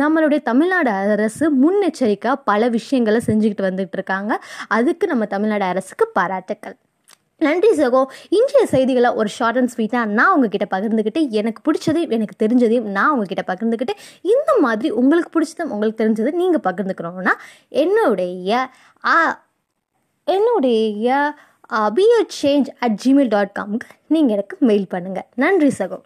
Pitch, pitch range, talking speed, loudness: 245 Hz, 210-305 Hz, 125 wpm, -18 LUFS